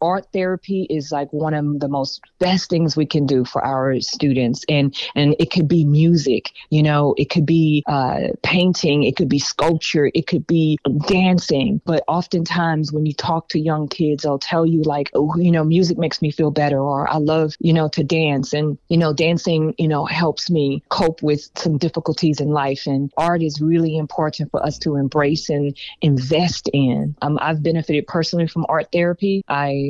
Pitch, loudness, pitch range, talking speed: 155 Hz, -18 LUFS, 145-165 Hz, 195 wpm